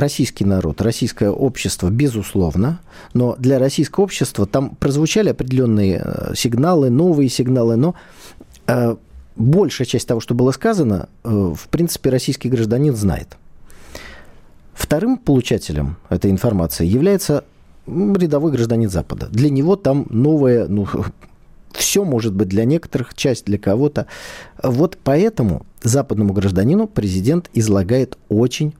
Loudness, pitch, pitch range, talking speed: -17 LUFS, 125 Hz, 105-145 Hz, 120 wpm